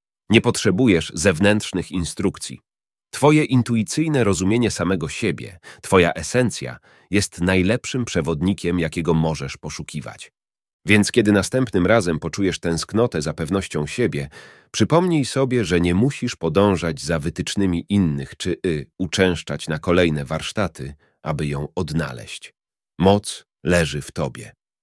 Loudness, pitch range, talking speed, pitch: -20 LUFS, 80-110 Hz, 115 wpm, 95 Hz